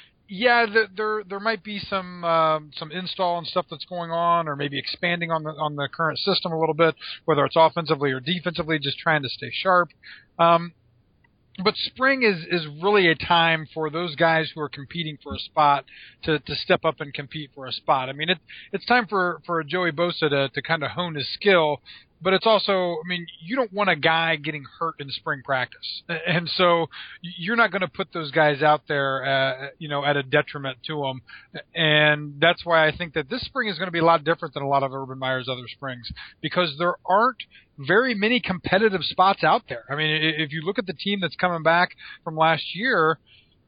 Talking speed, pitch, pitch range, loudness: 215 wpm, 165 Hz, 150-180 Hz, -23 LUFS